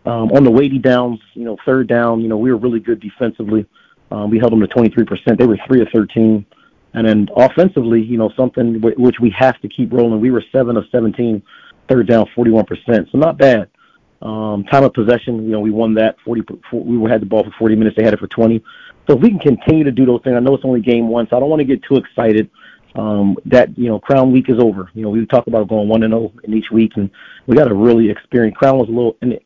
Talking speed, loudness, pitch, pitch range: 260 wpm, -14 LUFS, 115 Hz, 110-125 Hz